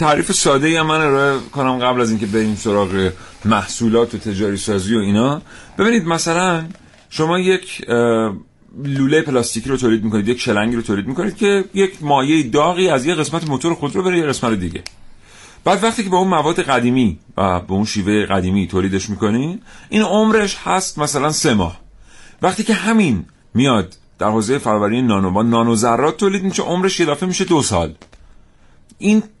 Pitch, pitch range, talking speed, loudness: 130 Hz, 105-180 Hz, 170 wpm, -17 LUFS